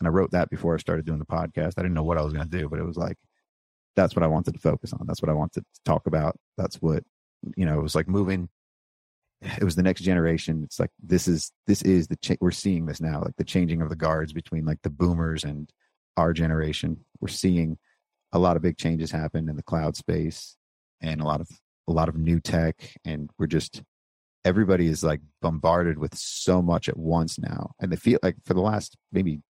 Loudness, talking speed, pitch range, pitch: -26 LUFS, 240 wpm, 80-90 Hz, 80 Hz